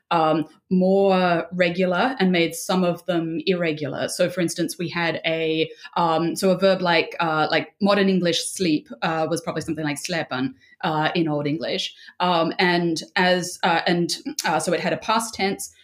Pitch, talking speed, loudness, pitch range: 170 Hz, 180 wpm, -22 LUFS, 160-185 Hz